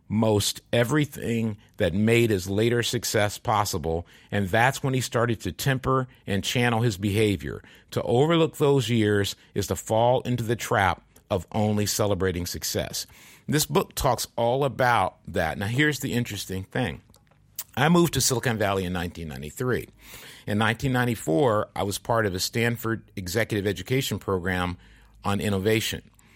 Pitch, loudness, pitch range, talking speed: 110 Hz, -25 LUFS, 100-120 Hz, 145 wpm